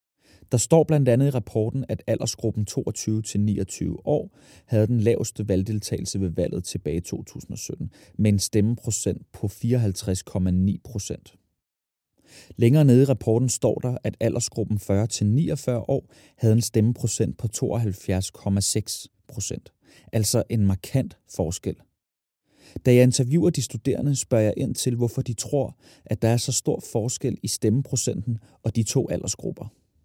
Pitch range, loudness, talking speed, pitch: 105-125 Hz, -24 LUFS, 140 wpm, 115 Hz